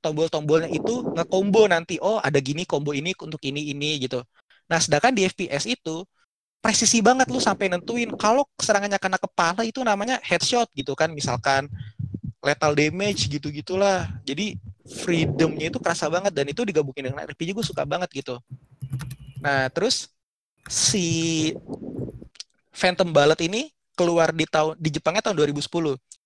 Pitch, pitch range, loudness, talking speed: 160 Hz, 140-195 Hz, -23 LUFS, 145 wpm